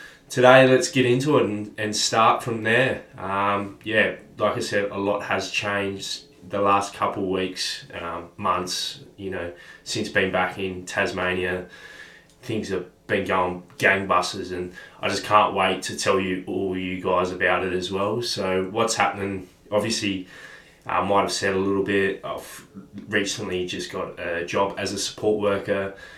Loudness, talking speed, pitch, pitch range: -23 LUFS, 165 wpm, 100 Hz, 90-100 Hz